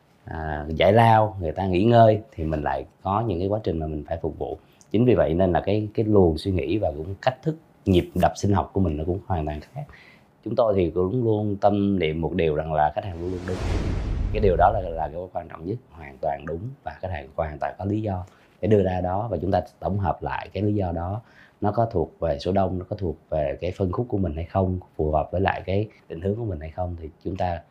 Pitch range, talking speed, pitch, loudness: 85-105 Hz, 275 wpm, 95 Hz, -24 LUFS